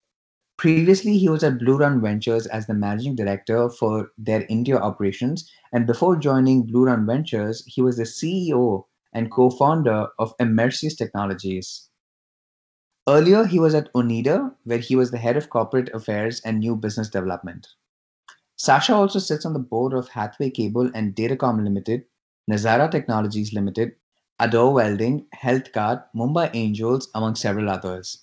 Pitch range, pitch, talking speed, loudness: 110-135 Hz, 120 Hz, 150 wpm, -21 LUFS